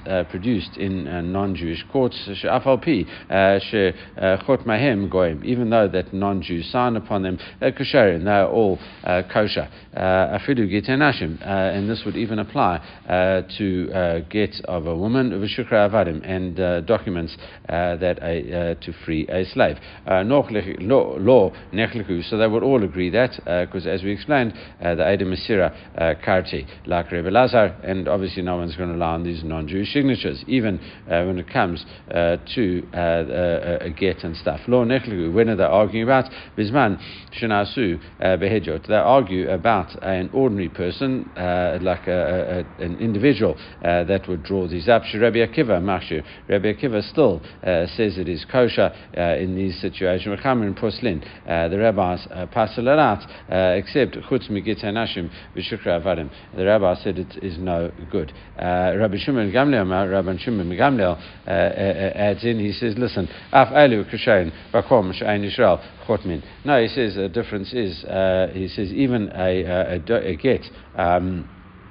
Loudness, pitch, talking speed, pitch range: -21 LUFS, 95 Hz, 150 wpm, 90-110 Hz